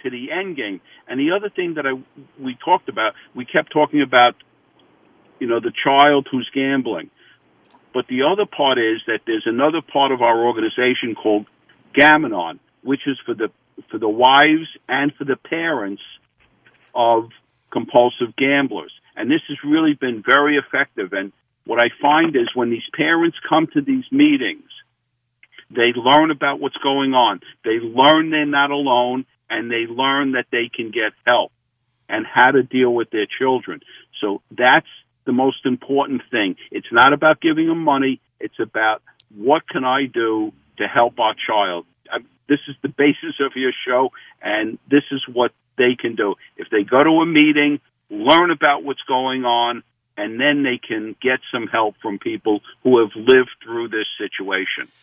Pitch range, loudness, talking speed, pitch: 125-155 Hz, -18 LUFS, 175 wpm, 135 Hz